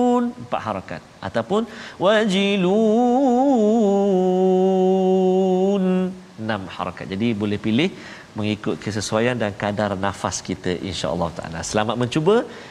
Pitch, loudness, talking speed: 125 Hz, -20 LUFS, 90 wpm